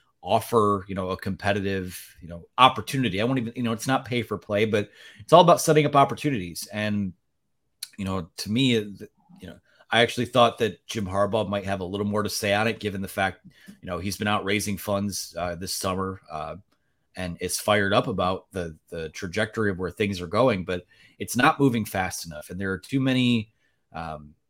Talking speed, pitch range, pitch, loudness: 210 wpm, 95-115 Hz, 100 Hz, -25 LUFS